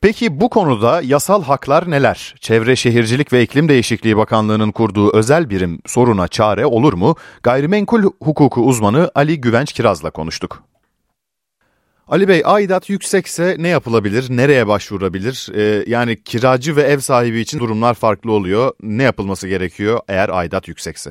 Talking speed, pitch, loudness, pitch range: 140 wpm, 120 Hz, -15 LUFS, 105-145 Hz